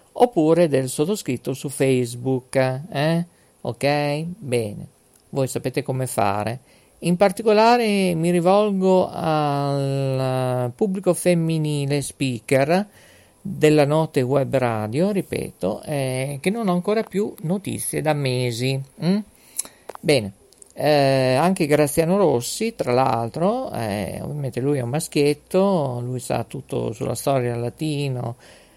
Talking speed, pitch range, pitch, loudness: 115 wpm, 130-175 Hz, 145 Hz, -21 LUFS